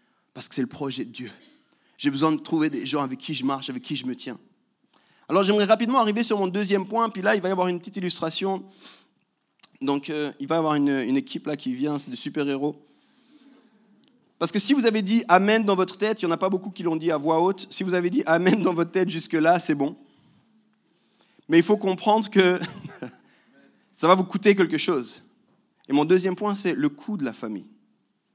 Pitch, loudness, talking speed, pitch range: 185 Hz, -24 LUFS, 230 wpm, 160-215 Hz